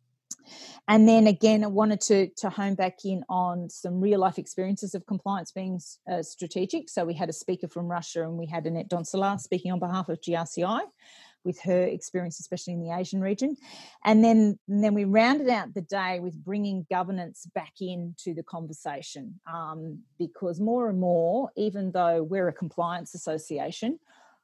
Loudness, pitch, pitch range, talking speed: -27 LUFS, 185 Hz, 175-205 Hz, 175 wpm